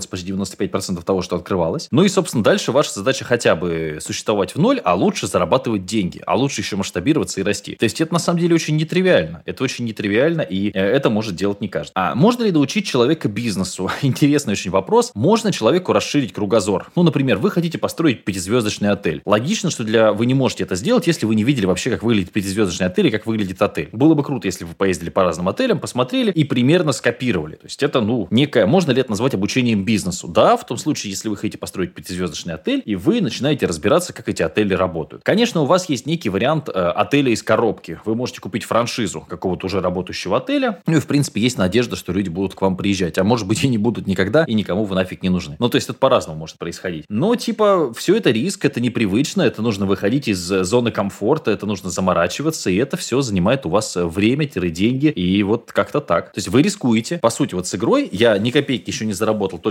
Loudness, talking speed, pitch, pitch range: -19 LUFS, 220 wpm, 110 Hz, 95-145 Hz